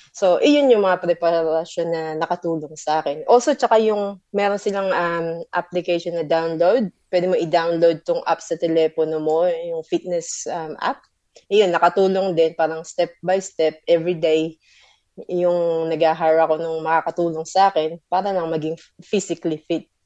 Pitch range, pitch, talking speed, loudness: 160-190 Hz, 170 Hz, 155 wpm, -20 LUFS